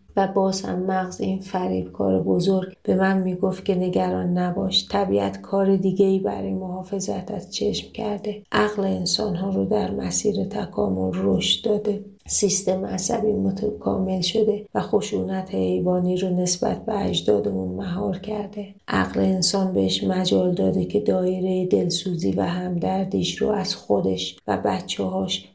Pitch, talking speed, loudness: 185 Hz, 145 wpm, -23 LUFS